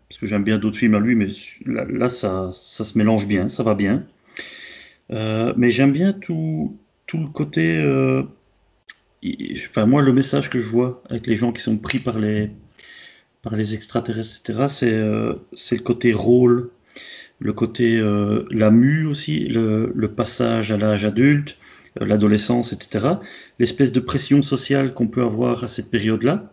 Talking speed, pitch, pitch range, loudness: 175 wpm, 120 Hz, 110-130 Hz, -20 LUFS